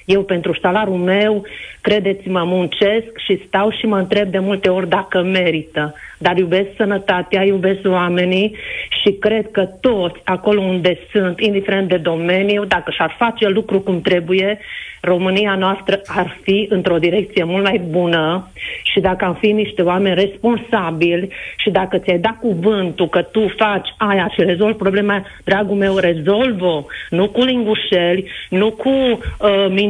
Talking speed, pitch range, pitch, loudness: 150 wpm, 180-205 Hz, 195 Hz, -16 LUFS